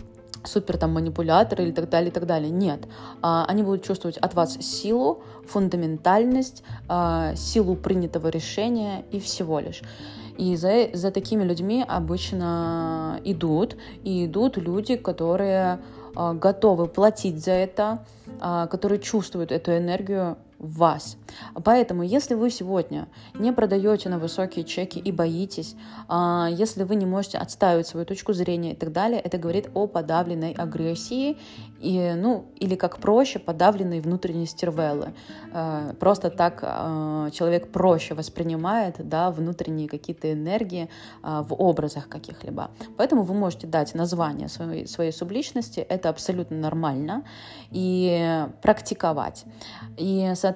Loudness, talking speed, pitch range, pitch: -25 LUFS, 130 wpm, 160-195 Hz, 175 Hz